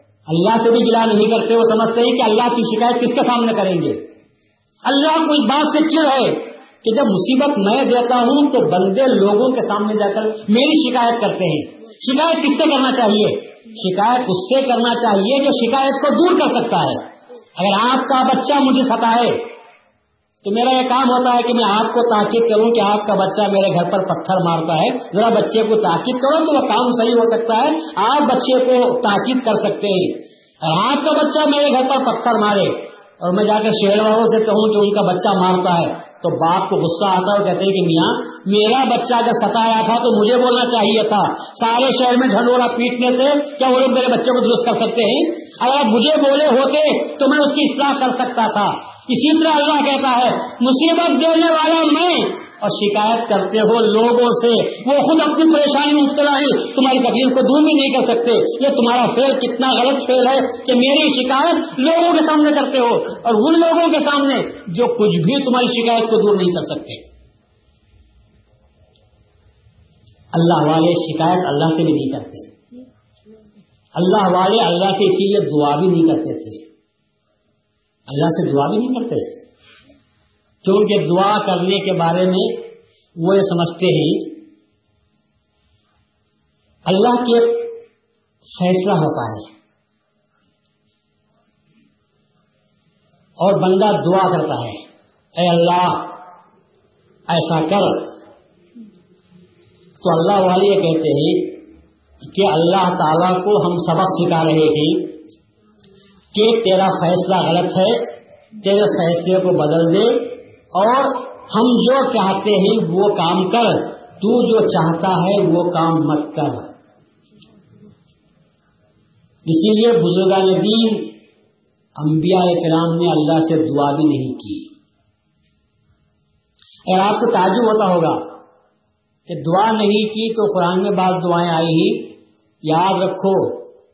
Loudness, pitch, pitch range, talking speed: -15 LUFS, 215 Hz, 180-255 Hz, 160 wpm